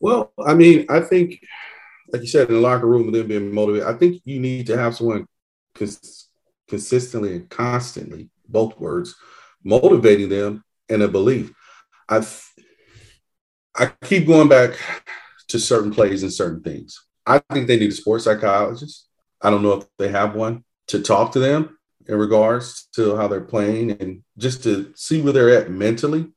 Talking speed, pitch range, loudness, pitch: 175 wpm, 105-135 Hz, -18 LUFS, 115 Hz